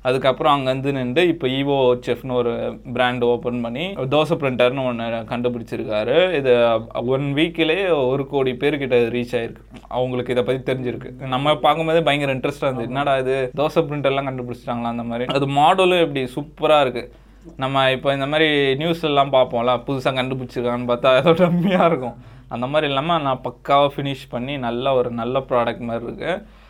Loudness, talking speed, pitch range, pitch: -20 LUFS, 155 wpm, 125-145 Hz, 130 Hz